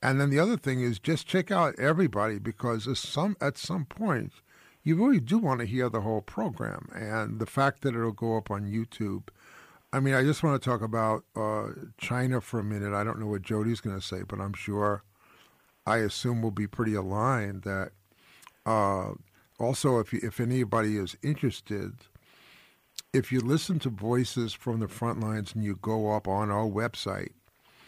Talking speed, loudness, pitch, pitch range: 190 wpm, -29 LUFS, 115 Hz, 105-130 Hz